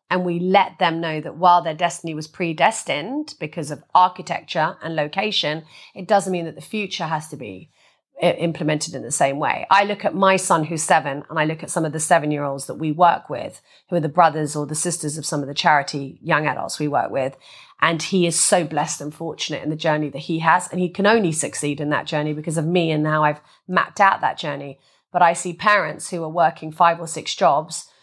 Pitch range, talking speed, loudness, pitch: 150-180 Hz, 235 wpm, -20 LUFS, 165 Hz